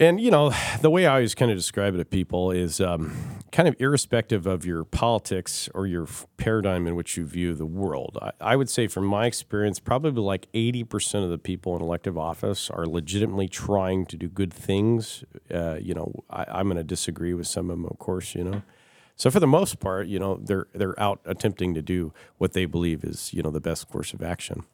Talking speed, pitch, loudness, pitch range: 230 wpm, 95 Hz, -26 LUFS, 85-110 Hz